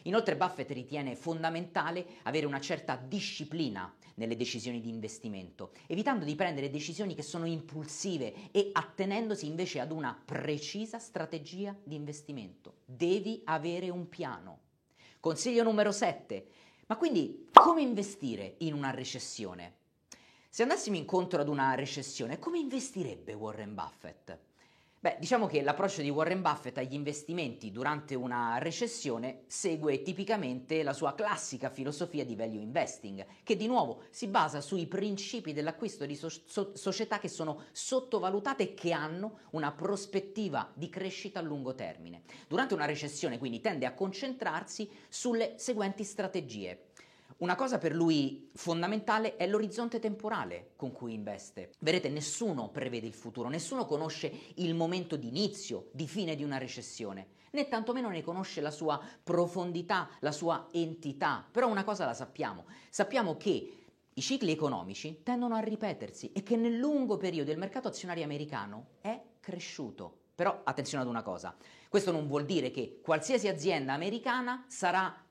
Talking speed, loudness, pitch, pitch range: 145 wpm, -34 LUFS, 165 Hz, 145-205 Hz